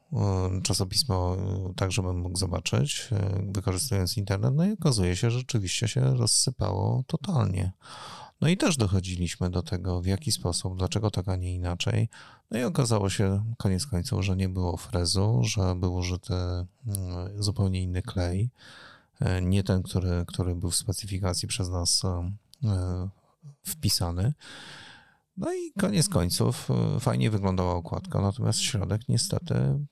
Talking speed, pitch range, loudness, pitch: 130 wpm, 90-110 Hz, -28 LUFS, 95 Hz